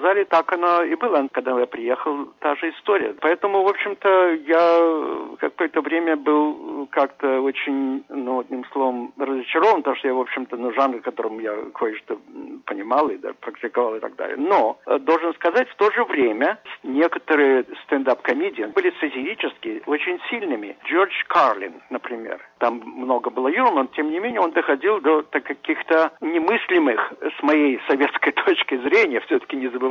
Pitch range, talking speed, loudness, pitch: 135-205 Hz, 155 wpm, -21 LUFS, 160 Hz